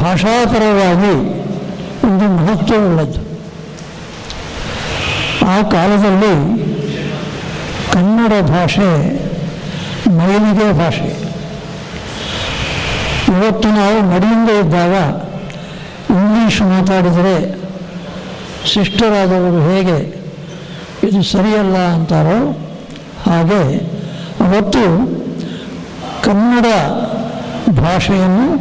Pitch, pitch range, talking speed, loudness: 190 Hz, 175-210 Hz, 50 wpm, -13 LUFS